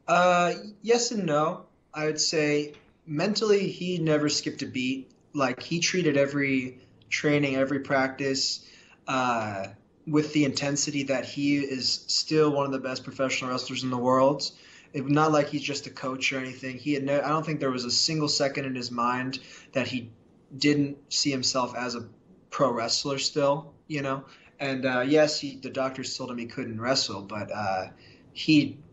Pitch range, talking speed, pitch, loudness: 130-150 Hz, 180 wpm, 140 Hz, -27 LUFS